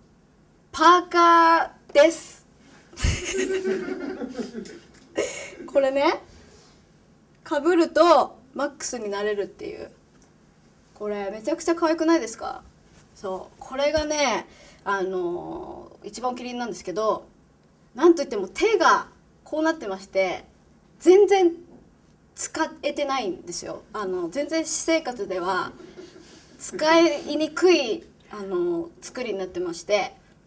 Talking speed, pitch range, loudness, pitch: 225 characters per minute, 210-340 Hz, -23 LUFS, 305 Hz